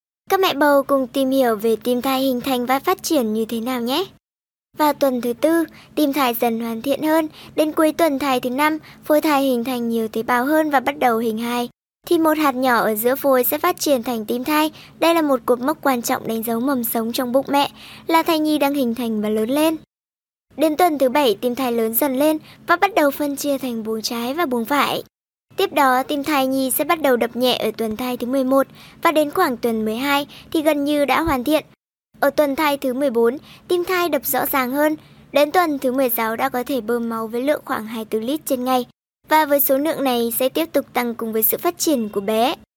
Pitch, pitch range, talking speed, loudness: 270 Hz, 245-300 Hz, 240 wpm, -19 LUFS